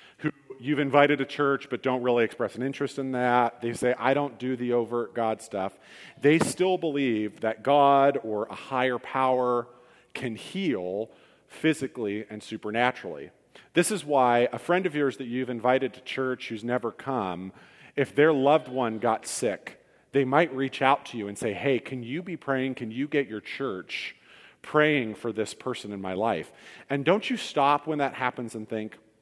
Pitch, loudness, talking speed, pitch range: 130 Hz, -27 LUFS, 185 wpm, 115-140 Hz